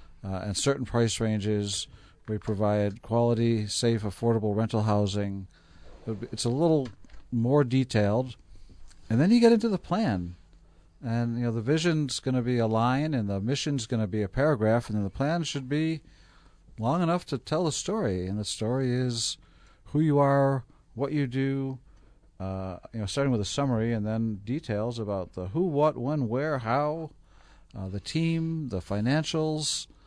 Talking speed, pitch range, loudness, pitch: 170 wpm, 105-140 Hz, -28 LUFS, 115 Hz